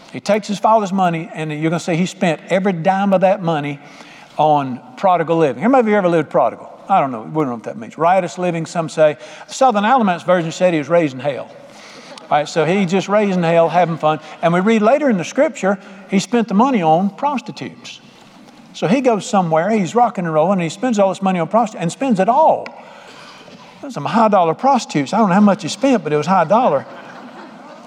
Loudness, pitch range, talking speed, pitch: -16 LUFS, 165-215 Hz, 225 wpm, 185 Hz